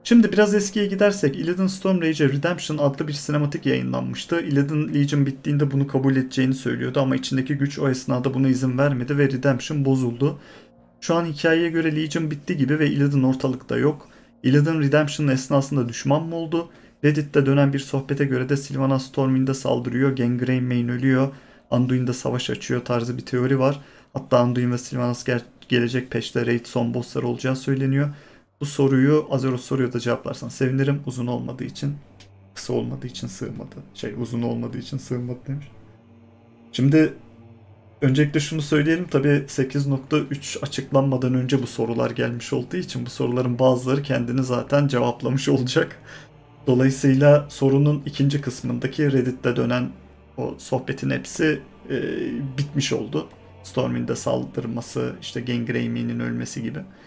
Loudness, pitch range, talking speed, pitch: -22 LUFS, 125-145 Hz, 140 wpm, 135 Hz